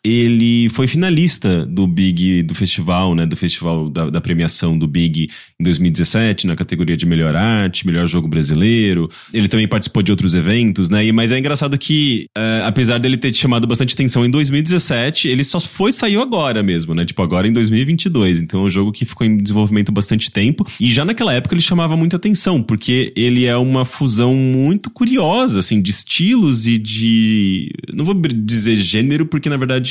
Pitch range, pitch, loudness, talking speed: 95-140 Hz, 115 Hz, -15 LUFS, 190 wpm